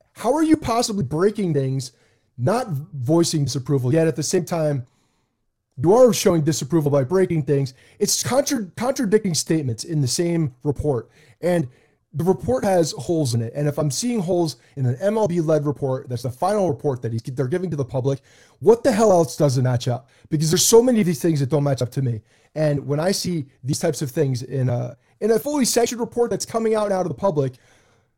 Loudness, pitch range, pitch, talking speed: -21 LUFS, 130-185 Hz, 150 Hz, 215 wpm